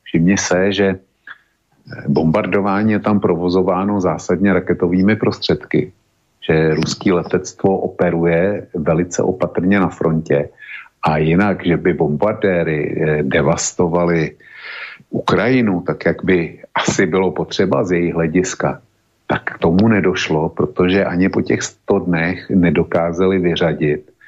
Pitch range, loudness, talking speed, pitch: 85-95 Hz, -16 LUFS, 115 wpm, 90 Hz